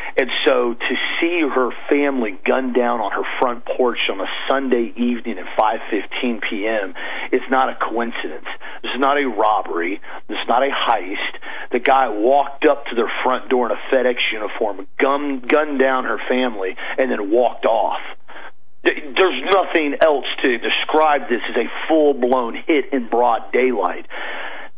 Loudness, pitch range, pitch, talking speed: -19 LUFS, 125-150 Hz, 135 Hz, 160 wpm